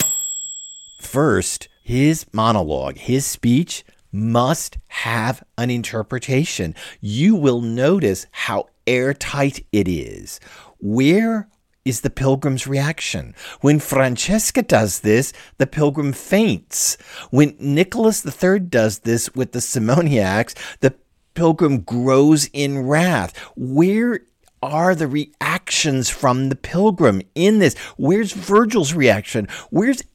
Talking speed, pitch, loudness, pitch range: 105 wpm, 135 Hz, -18 LUFS, 115-165 Hz